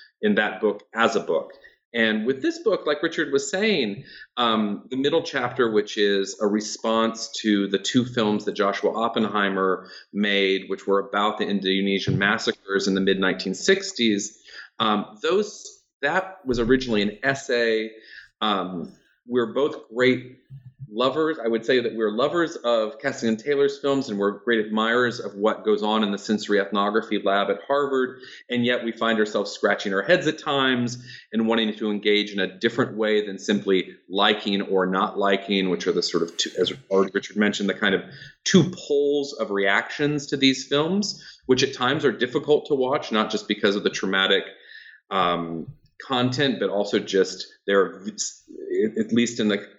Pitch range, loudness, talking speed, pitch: 100-135 Hz, -23 LUFS, 175 wpm, 115 Hz